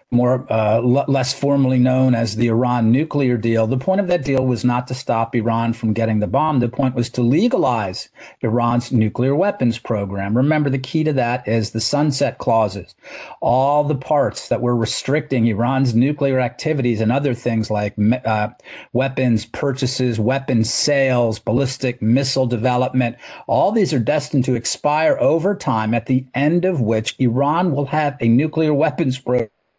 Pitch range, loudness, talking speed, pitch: 115-140 Hz, -18 LUFS, 170 wpm, 125 Hz